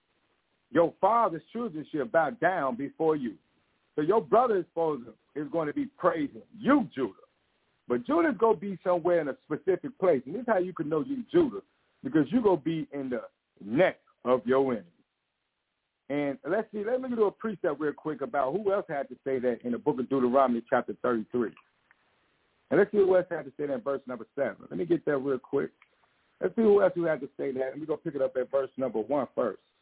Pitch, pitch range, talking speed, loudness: 155 Hz, 135-210 Hz, 225 wpm, -29 LUFS